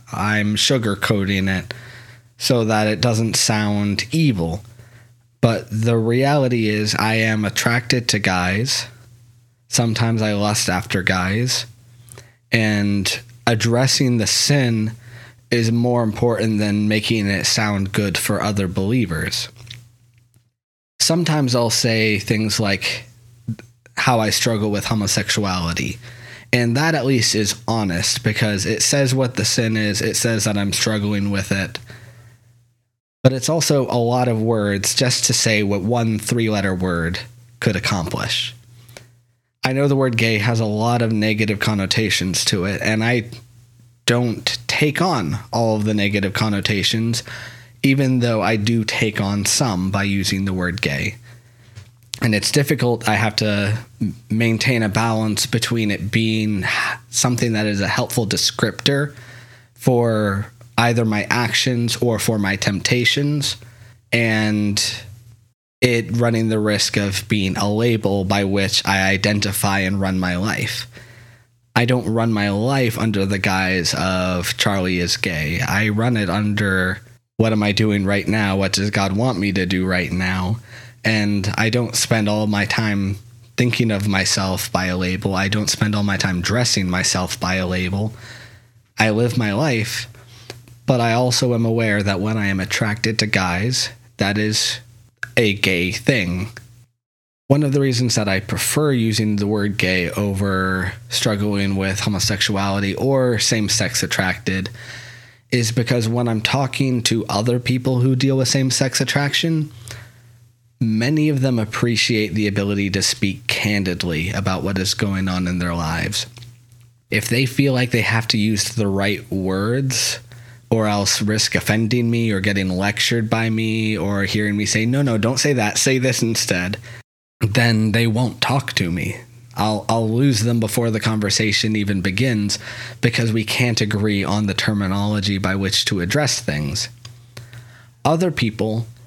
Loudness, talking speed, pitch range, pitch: -19 LUFS, 150 wpm, 105-120 Hz, 115 Hz